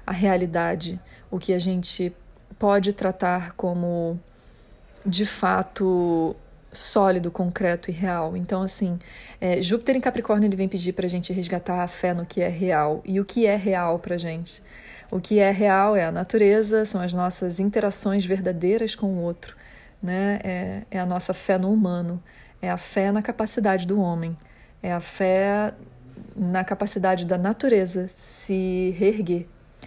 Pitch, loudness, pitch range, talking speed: 185 Hz, -22 LUFS, 175-200 Hz, 165 wpm